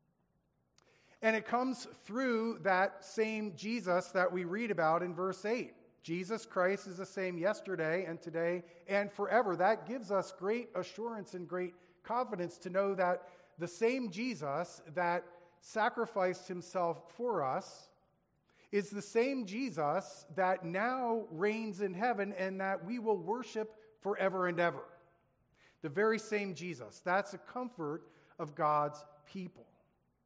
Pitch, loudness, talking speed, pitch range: 190 Hz, -36 LUFS, 140 wpm, 175-220 Hz